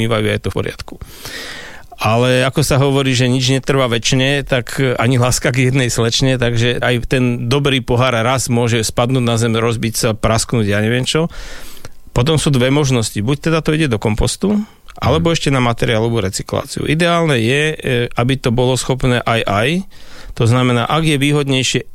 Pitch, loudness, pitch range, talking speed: 125 Hz, -15 LUFS, 120-140 Hz, 170 wpm